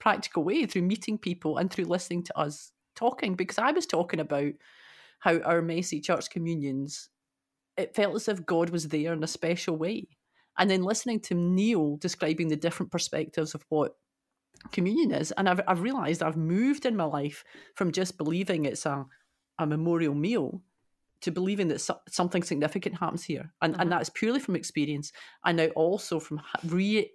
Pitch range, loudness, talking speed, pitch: 155-190 Hz, -29 LUFS, 175 wpm, 175 Hz